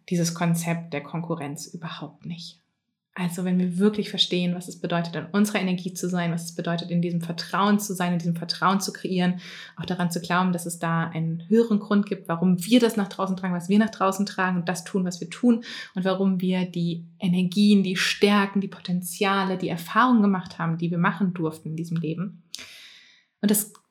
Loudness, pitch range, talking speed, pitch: -24 LUFS, 170-195 Hz, 205 wpm, 180 Hz